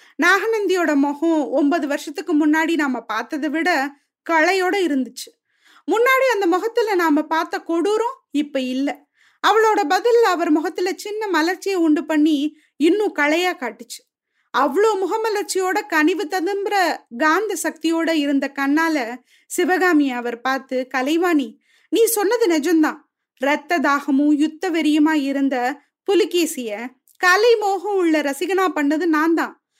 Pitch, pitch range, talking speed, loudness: 320 Hz, 290-375 Hz, 115 wpm, -19 LUFS